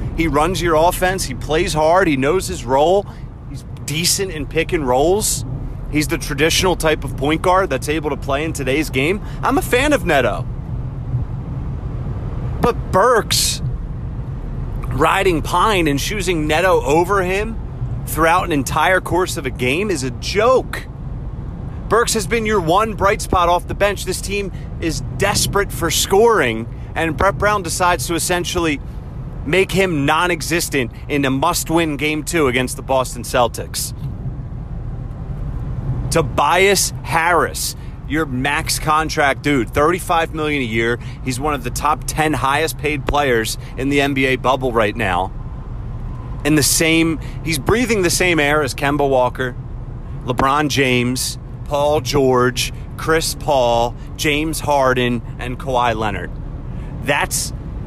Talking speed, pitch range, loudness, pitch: 140 wpm, 125-160 Hz, -17 LUFS, 140 Hz